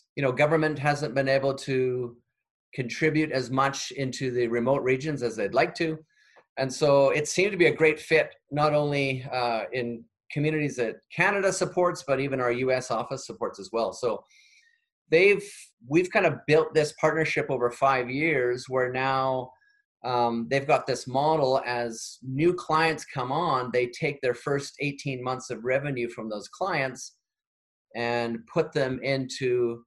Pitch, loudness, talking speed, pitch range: 135 Hz, -26 LUFS, 165 wpm, 125-155 Hz